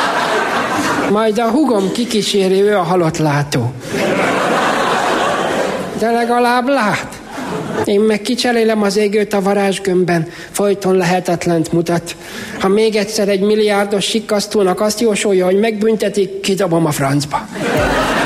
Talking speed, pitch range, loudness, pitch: 110 wpm, 180-215 Hz, -15 LUFS, 200 Hz